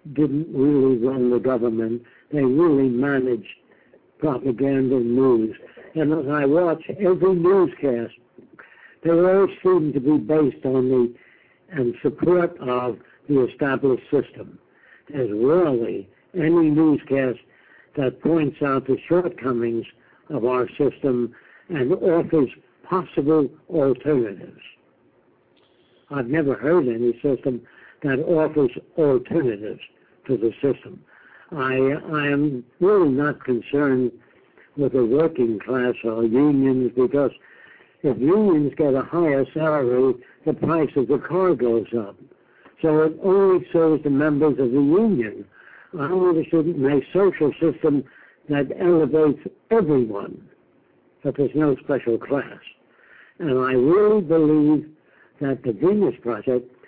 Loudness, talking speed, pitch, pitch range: -21 LUFS, 120 wpm, 140 Hz, 125-160 Hz